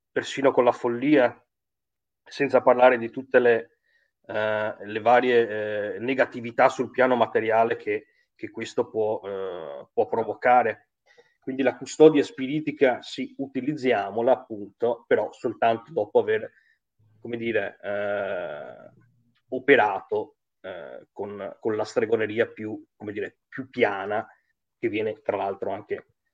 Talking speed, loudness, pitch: 125 wpm, -24 LUFS, 130 Hz